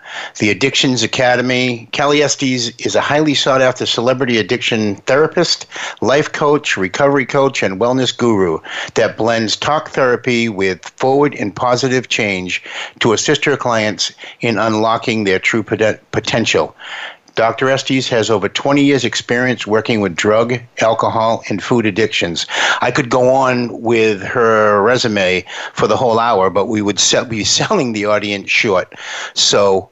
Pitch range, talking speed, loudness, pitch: 110-130 Hz, 145 wpm, -14 LUFS, 115 Hz